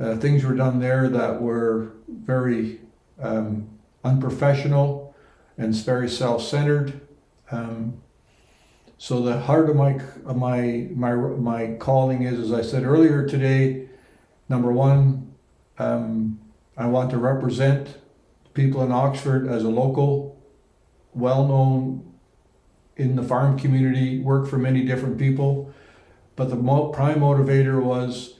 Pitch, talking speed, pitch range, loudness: 130 Hz, 130 wpm, 120-140 Hz, -22 LUFS